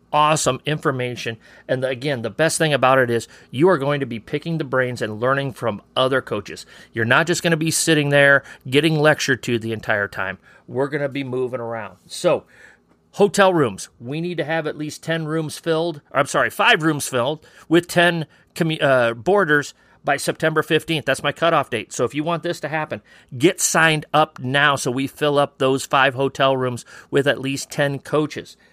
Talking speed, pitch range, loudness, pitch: 205 wpm, 130-160 Hz, -20 LUFS, 145 Hz